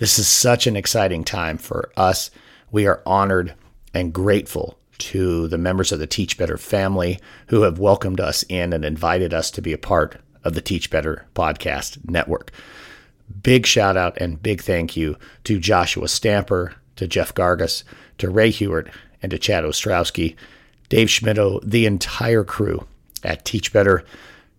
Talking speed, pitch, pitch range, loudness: 165 wpm, 95 Hz, 85-105 Hz, -20 LUFS